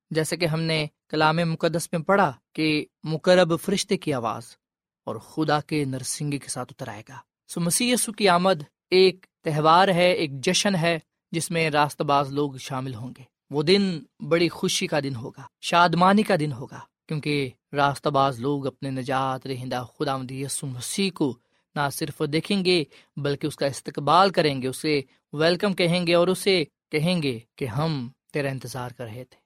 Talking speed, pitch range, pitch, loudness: 180 wpm, 135-175 Hz, 155 Hz, -24 LUFS